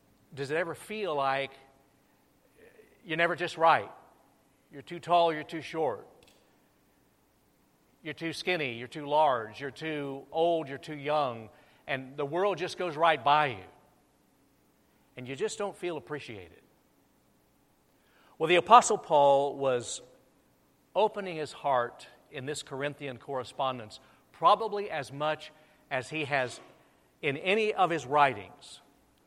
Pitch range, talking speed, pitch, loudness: 135-165 Hz, 130 wpm, 150 Hz, -29 LUFS